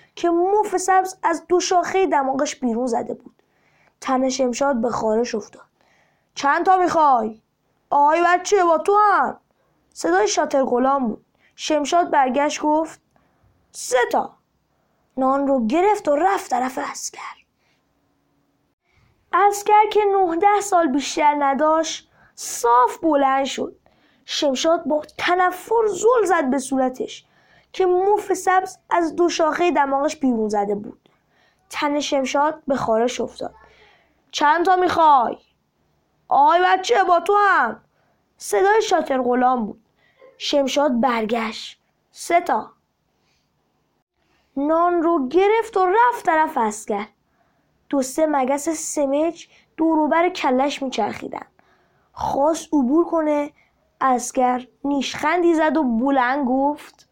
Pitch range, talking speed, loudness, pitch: 270-365 Hz, 115 wpm, -19 LUFS, 310 Hz